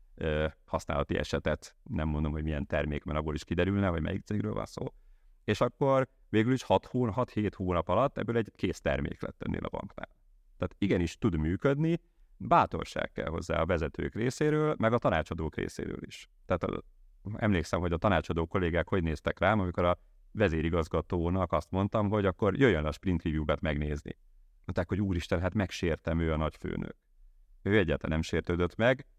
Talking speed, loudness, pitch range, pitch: 165 wpm, -31 LUFS, 80-105 Hz, 90 Hz